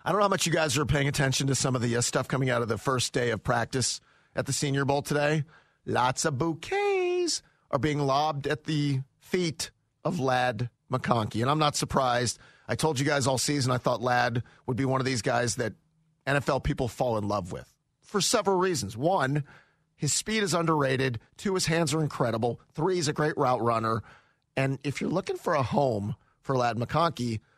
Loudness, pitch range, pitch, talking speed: -28 LUFS, 125-155 Hz, 140 Hz, 210 wpm